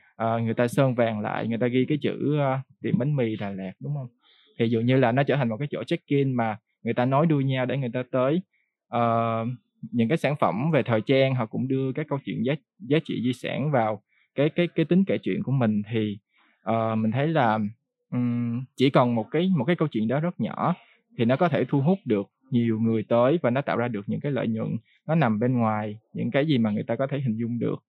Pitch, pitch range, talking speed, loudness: 125 Hz, 115-145 Hz, 255 wpm, -25 LUFS